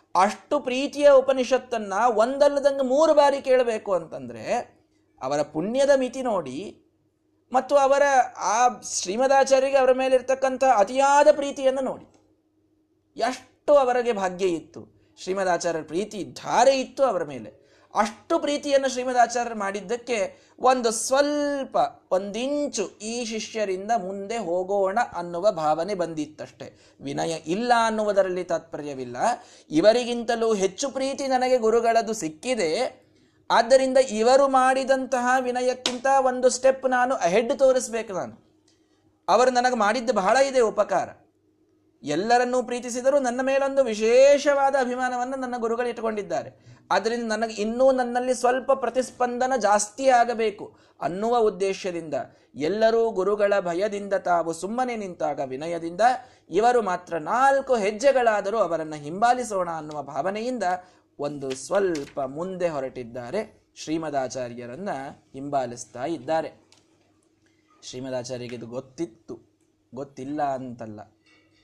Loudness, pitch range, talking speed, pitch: -23 LUFS, 185-265 Hz, 100 wpm, 240 Hz